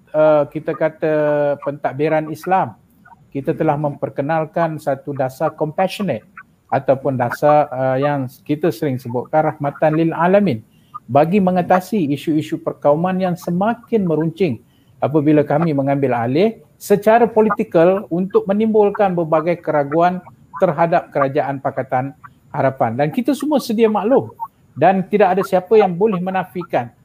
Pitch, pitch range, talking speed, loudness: 160 Hz, 145-190 Hz, 120 wpm, -17 LUFS